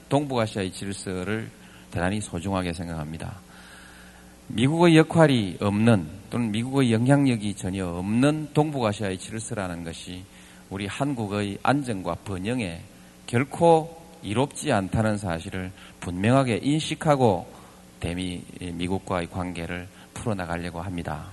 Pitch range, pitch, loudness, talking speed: 90-120 Hz, 100 Hz, -25 LUFS, 285 characters per minute